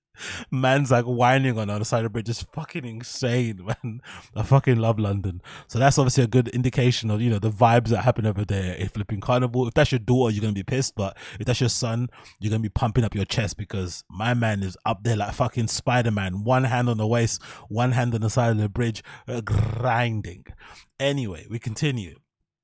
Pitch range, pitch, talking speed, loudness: 105-125 Hz, 115 Hz, 225 wpm, -24 LUFS